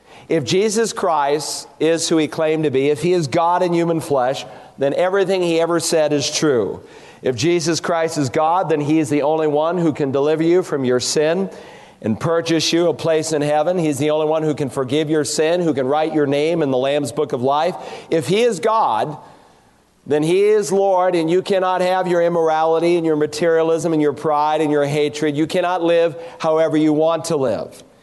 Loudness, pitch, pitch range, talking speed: -18 LUFS, 160 Hz, 150-170 Hz, 210 wpm